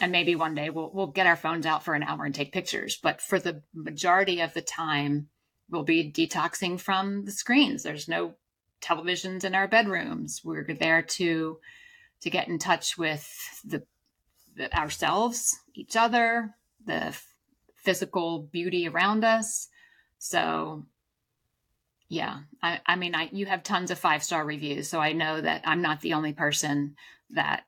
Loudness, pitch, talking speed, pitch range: -27 LUFS, 170 Hz, 165 wpm, 155-195 Hz